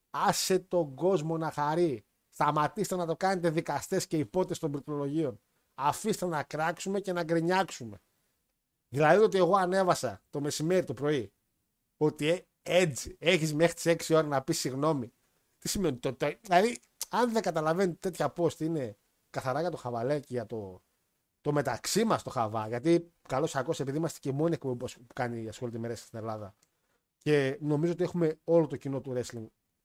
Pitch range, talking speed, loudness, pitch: 135-175 Hz, 165 wpm, -30 LUFS, 155 Hz